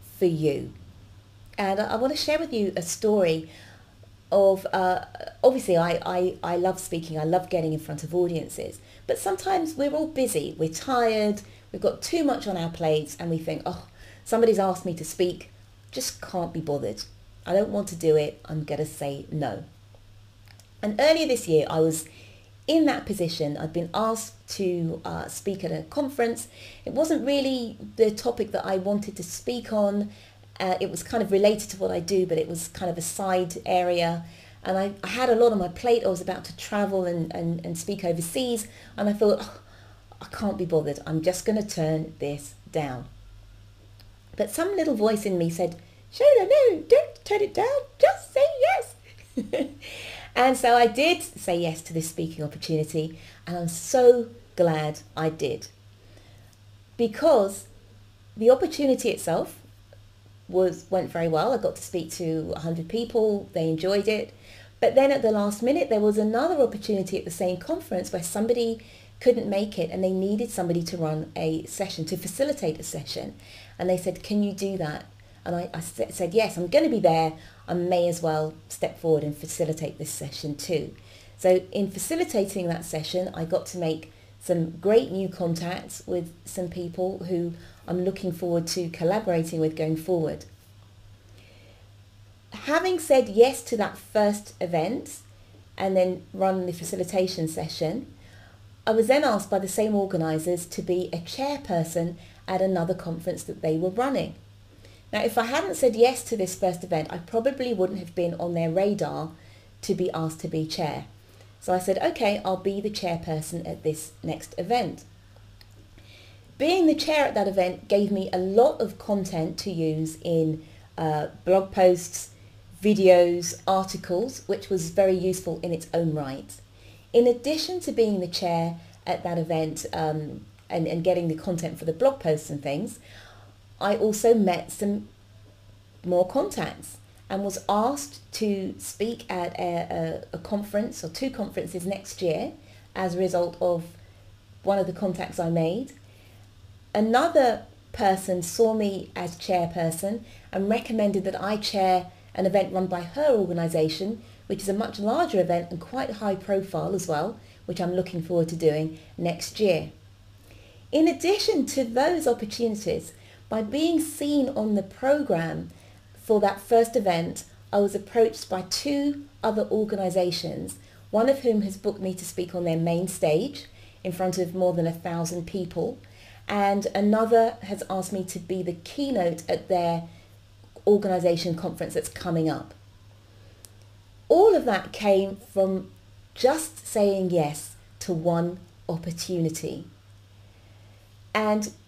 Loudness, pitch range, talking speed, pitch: -26 LUFS, 150-205 Hz, 165 wpm, 175 Hz